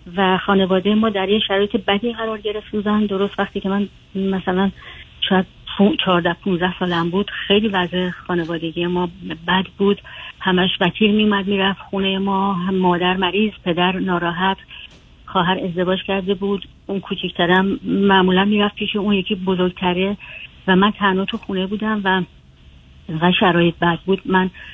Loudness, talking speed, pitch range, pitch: -19 LUFS, 150 wpm, 180-200 Hz, 190 Hz